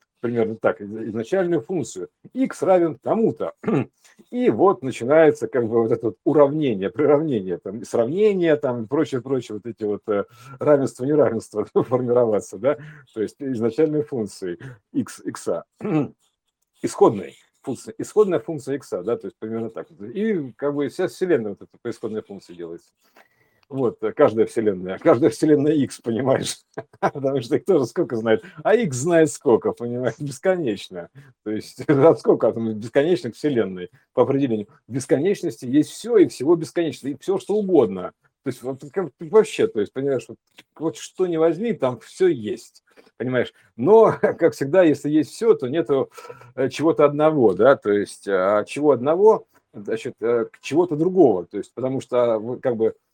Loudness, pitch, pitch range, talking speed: -21 LUFS, 145 Hz, 120-175 Hz, 155 wpm